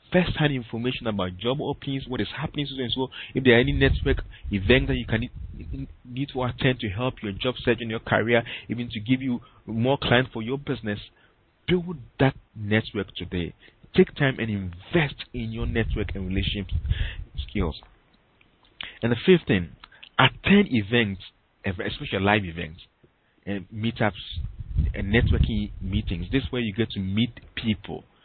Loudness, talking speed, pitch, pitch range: -25 LUFS, 160 wpm, 115 Hz, 100-130 Hz